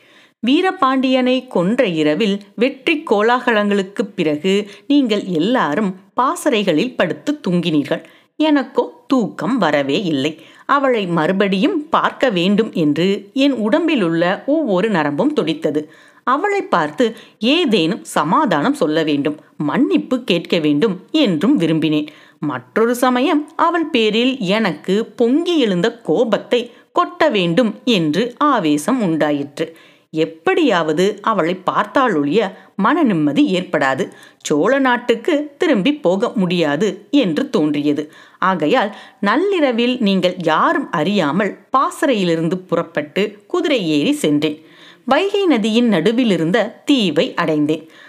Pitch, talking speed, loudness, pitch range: 215 Hz, 95 wpm, -17 LUFS, 170-270 Hz